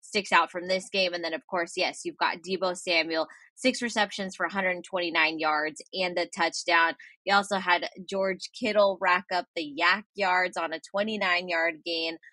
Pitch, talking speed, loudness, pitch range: 180 Hz, 180 wpm, -27 LUFS, 170-195 Hz